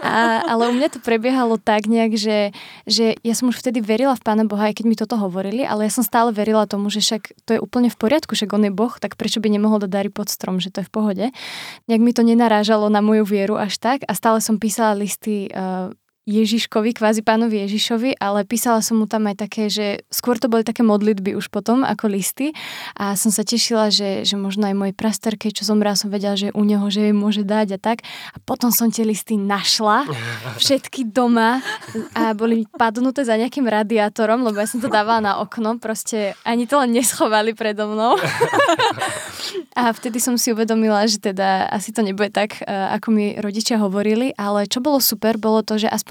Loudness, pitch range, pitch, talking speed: -19 LUFS, 210-230 Hz, 220 Hz, 210 wpm